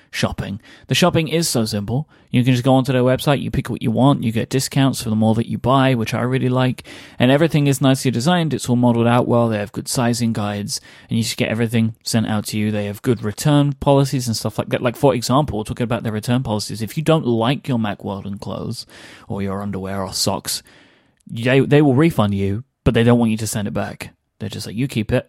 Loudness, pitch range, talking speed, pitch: -19 LUFS, 110-135 Hz, 250 wpm, 120 Hz